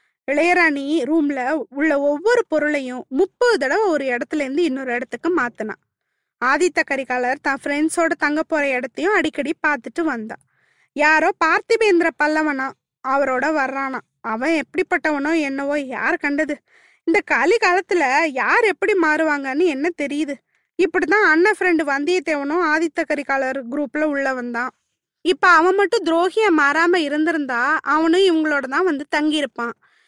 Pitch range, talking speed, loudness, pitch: 280-350 Hz, 120 wpm, -19 LUFS, 310 Hz